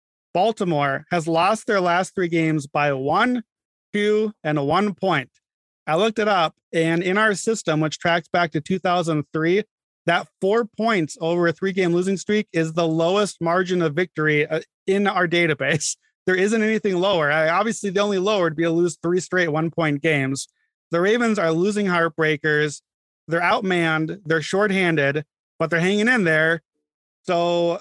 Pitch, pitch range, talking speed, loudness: 175 Hz, 160-195 Hz, 165 wpm, -21 LUFS